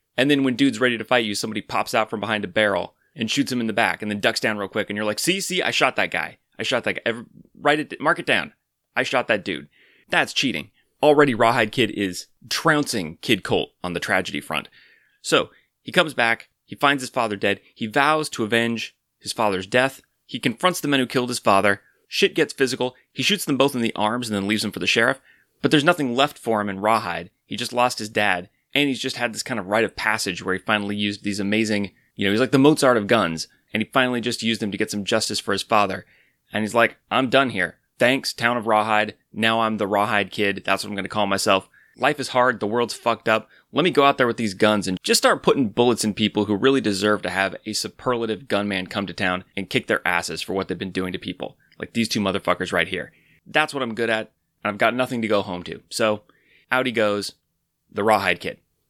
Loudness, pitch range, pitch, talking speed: -22 LUFS, 100-130 Hz, 110 Hz, 250 wpm